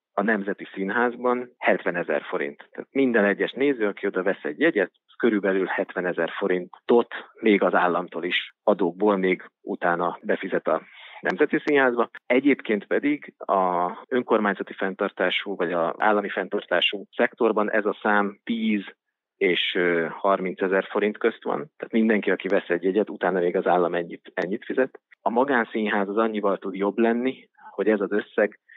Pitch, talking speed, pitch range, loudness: 105 Hz, 155 wpm, 95-120 Hz, -24 LUFS